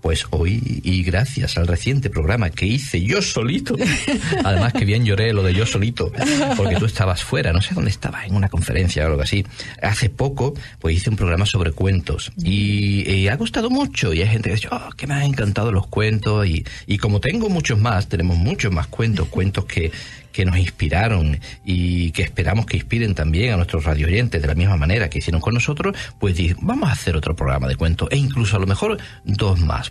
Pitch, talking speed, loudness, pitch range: 100 Hz, 215 wpm, -20 LUFS, 90-115 Hz